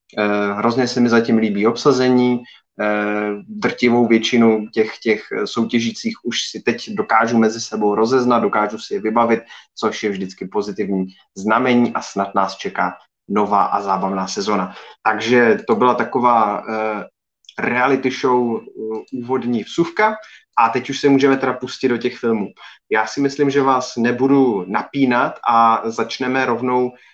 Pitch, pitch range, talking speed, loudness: 115 Hz, 110-125 Hz, 140 wpm, -18 LUFS